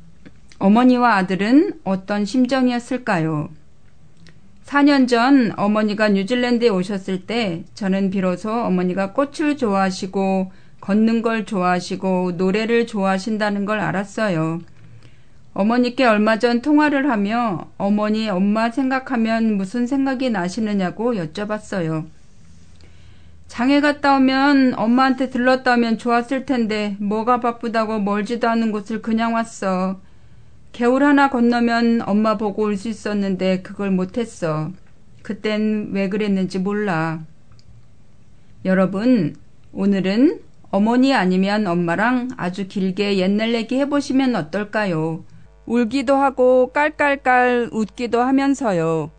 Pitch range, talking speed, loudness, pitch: 190-245 Hz, 265 characters per minute, -19 LUFS, 215 Hz